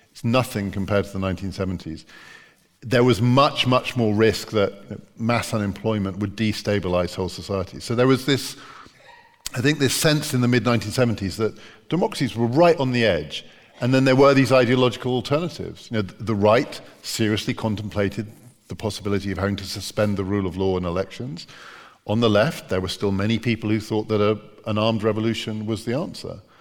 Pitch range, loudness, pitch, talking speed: 100-125 Hz, -22 LUFS, 110 Hz, 180 wpm